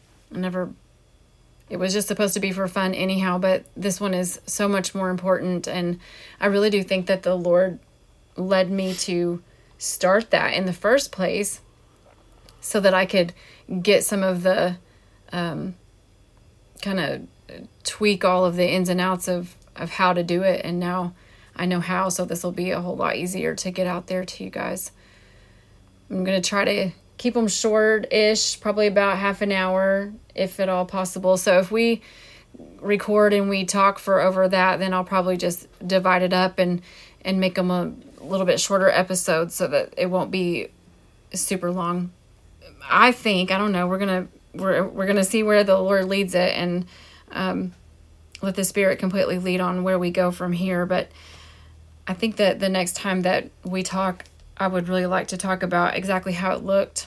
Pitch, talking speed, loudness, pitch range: 185 Hz, 190 wpm, -22 LUFS, 180-195 Hz